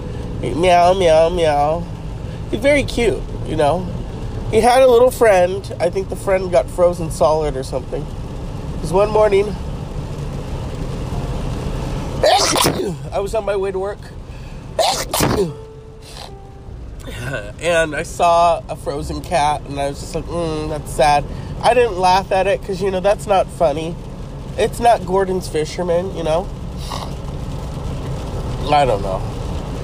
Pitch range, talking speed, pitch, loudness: 145-195 Hz, 135 wpm, 170 Hz, -18 LUFS